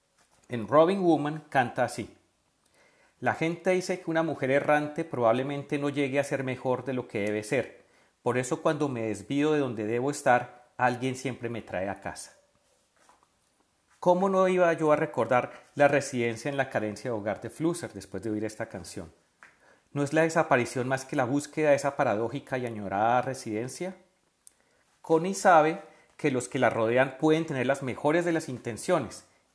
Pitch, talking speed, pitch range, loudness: 140 Hz, 175 wpm, 120-155 Hz, -28 LUFS